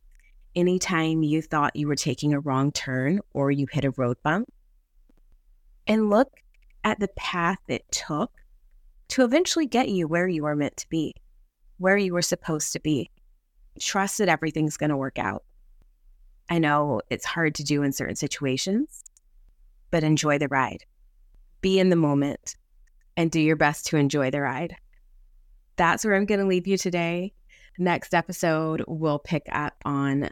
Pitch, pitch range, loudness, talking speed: 155 Hz, 140-180 Hz, -25 LUFS, 165 wpm